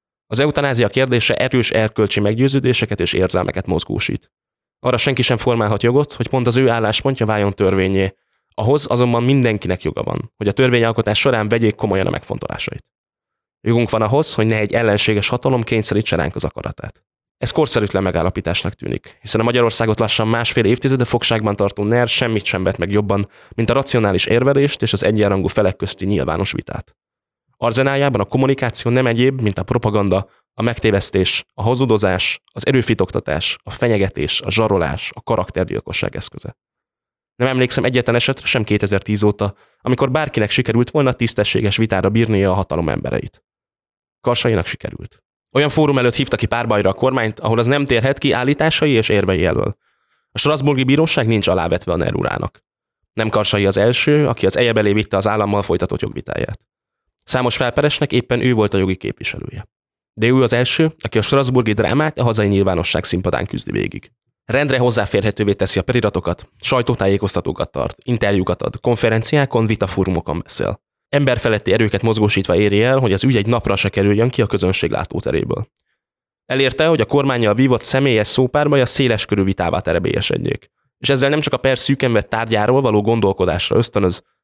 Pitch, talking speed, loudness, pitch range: 115 Hz, 160 wpm, -17 LUFS, 100-130 Hz